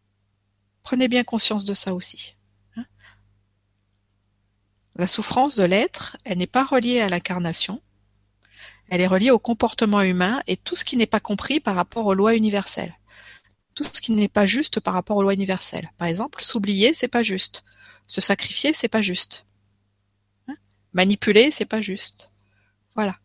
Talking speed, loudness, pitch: 165 wpm, -20 LUFS, 190 Hz